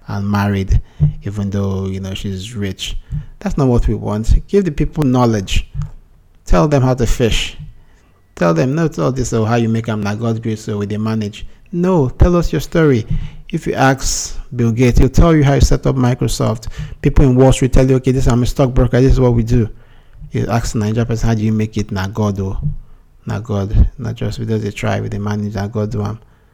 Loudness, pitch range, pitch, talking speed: -16 LUFS, 105-130 Hz, 115 Hz, 215 wpm